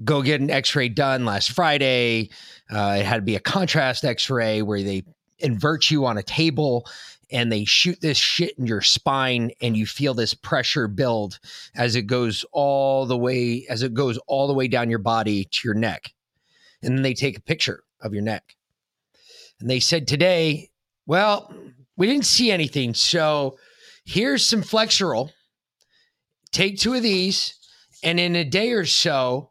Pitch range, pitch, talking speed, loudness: 115-160 Hz, 130 Hz, 180 wpm, -21 LUFS